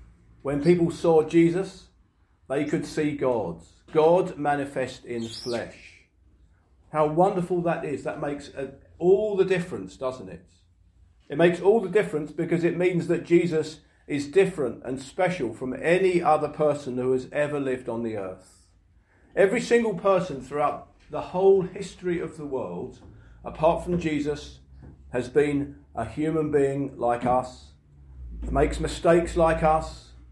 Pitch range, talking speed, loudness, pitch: 100-170 Hz, 145 wpm, -25 LUFS, 145 Hz